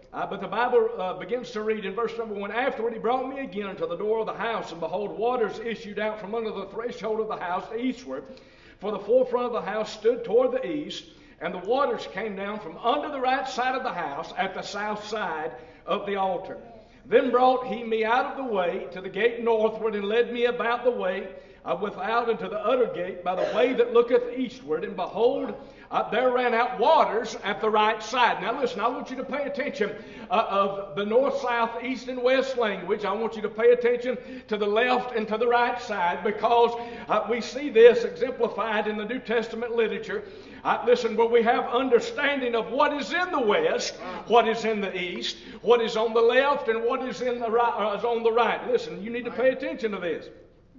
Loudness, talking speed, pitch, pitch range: -26 LUFS, 225 wpm, 235 Hz, 215-255 Hz